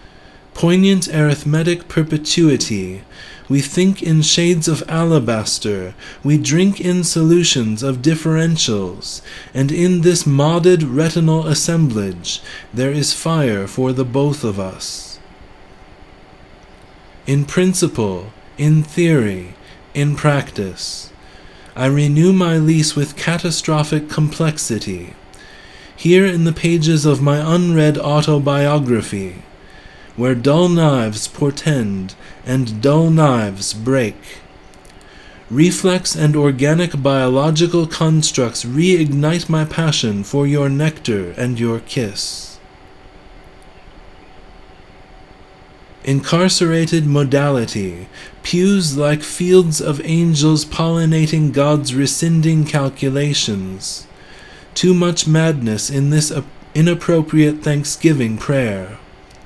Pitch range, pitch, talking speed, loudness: 100-160 Hz, 145 Hz, 95 wpm, -16 LUFS